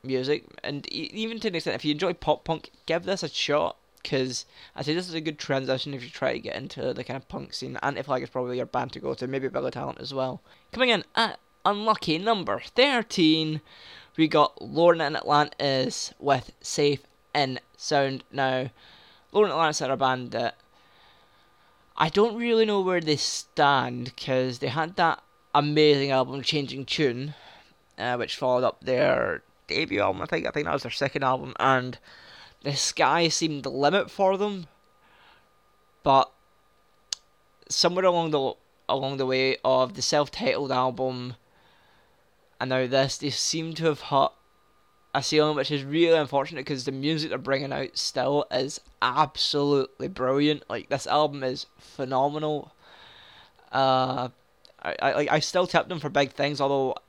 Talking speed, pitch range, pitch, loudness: 170 wpm, 130-160 Hz, 145 Hz, -26 LUFS